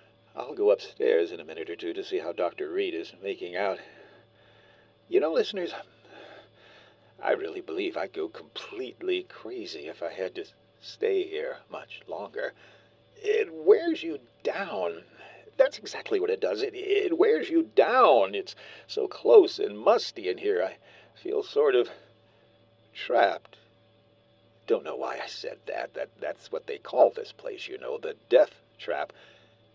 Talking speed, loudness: 155 wpm, -28 LUFS